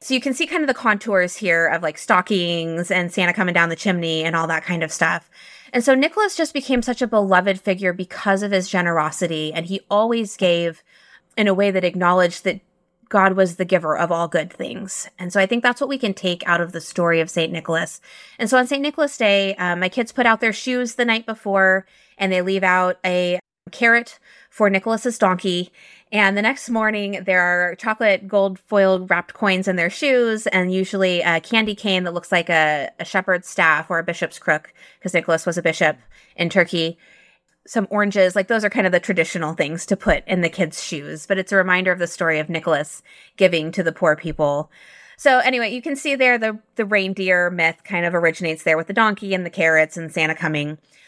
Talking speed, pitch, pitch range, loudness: 220 wpm, 185 Hz, 170-215 Hz, -19 LUFS